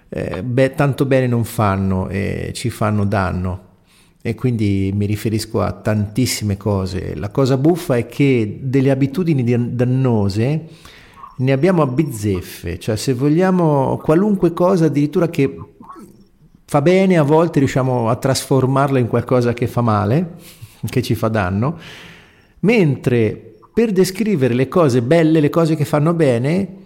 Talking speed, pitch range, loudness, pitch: 145 wpm, 110-155 Hz, -17 LUFS, 130 Hz